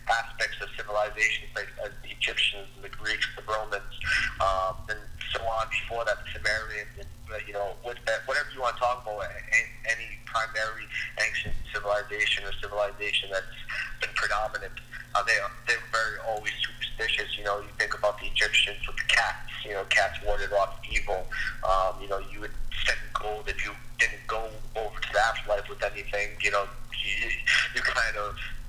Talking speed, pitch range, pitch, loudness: 180 wpm, 100-115 Hz, 110 Hz, -28 LUFS